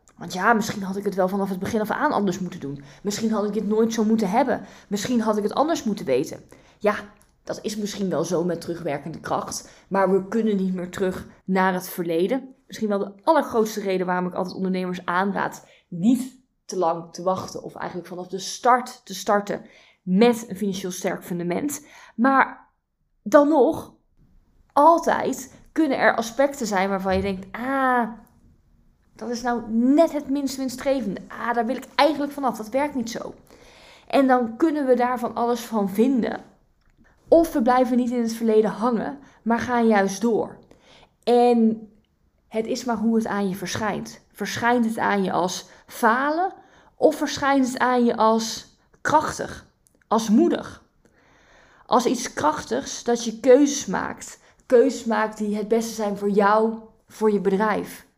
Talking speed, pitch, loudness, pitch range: 170 wpm, 220 Hz, -23 LUFS, 195-245 Hz